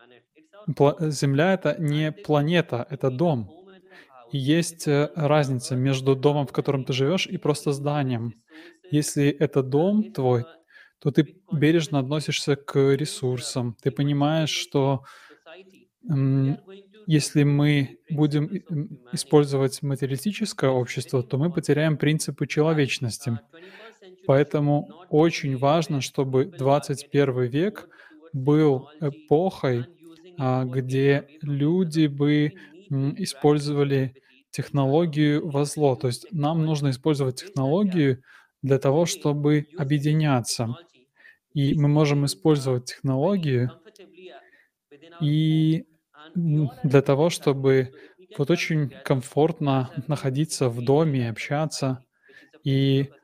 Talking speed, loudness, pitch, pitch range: 95 wpm, -24 LUFS, 145 Hz, 135-160 Hz